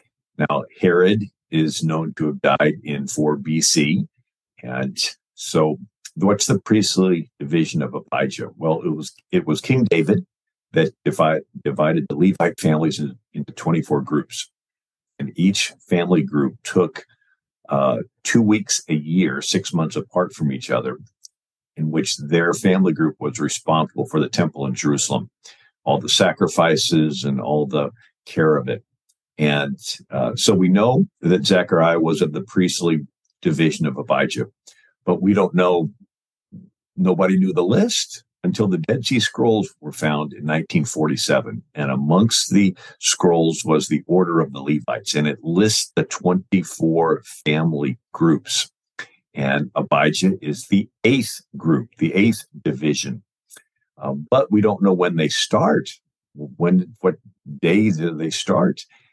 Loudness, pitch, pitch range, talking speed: -19 LUFS, 80 Hz, 75-95 Hz, 145 wpm